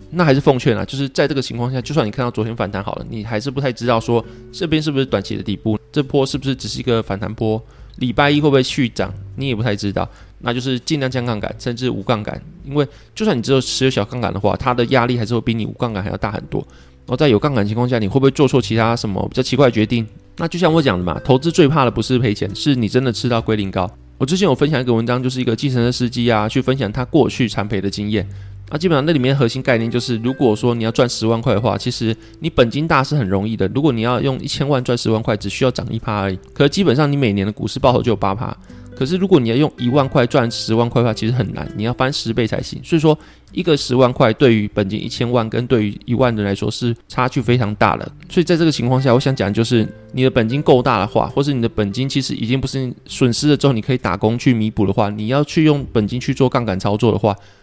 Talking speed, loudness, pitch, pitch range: 405 characters per minute, -17 LUFS, 120 Hz, 110-135 Hz